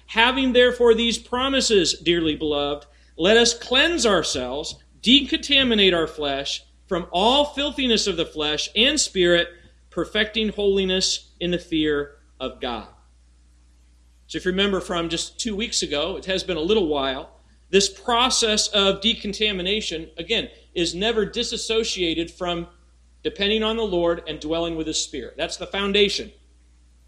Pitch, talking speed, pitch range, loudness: 190 Hz, 140 wpm, 160-225 Hz, -21 LUFS